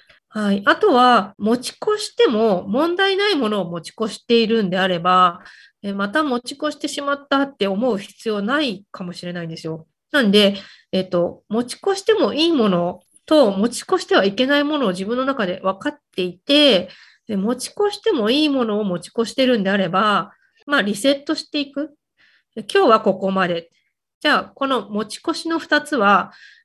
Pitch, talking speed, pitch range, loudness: 235 Hz, 345 characters per minute, 195-290 Hz, -19 LUFS